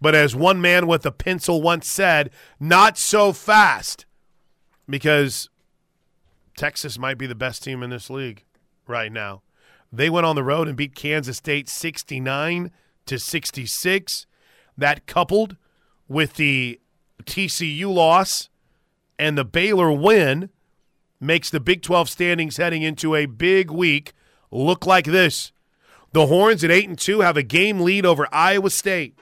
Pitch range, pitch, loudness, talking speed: 140-180 Hz, 165 Hz, -19 LUFS, 150 wpm